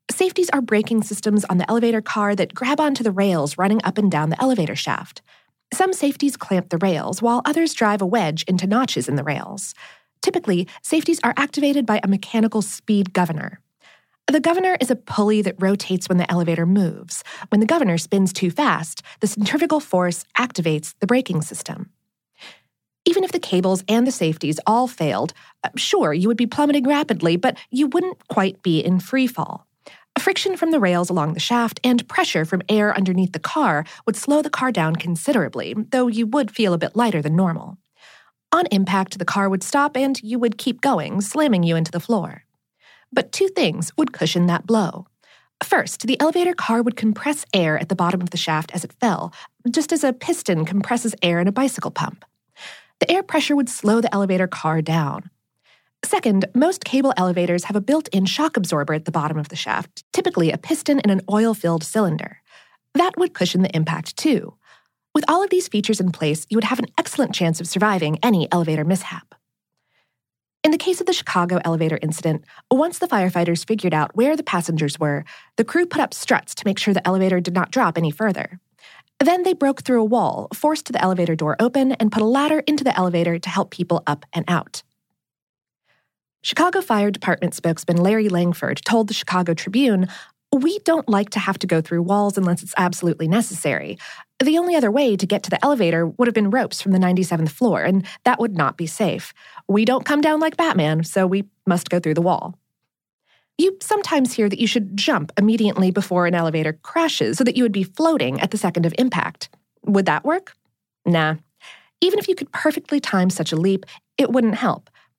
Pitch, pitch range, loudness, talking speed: 205 Hz, 175-265 Hz, -20 LUFS, 200 wpm